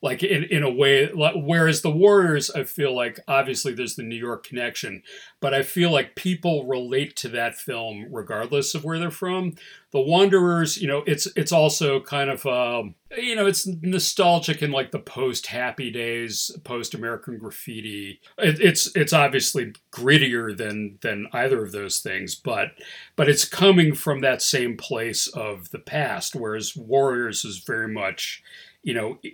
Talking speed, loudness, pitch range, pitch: 175 wpm, -22 LUFS, 120-170 Hz, 140 Hz